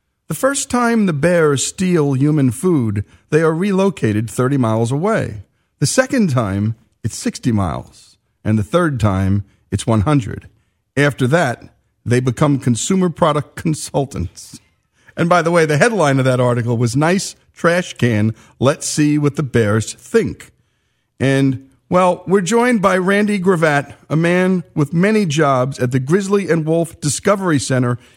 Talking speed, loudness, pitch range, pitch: 150 wpm, -16 LUFS, 115-175 Hz, 140 Hz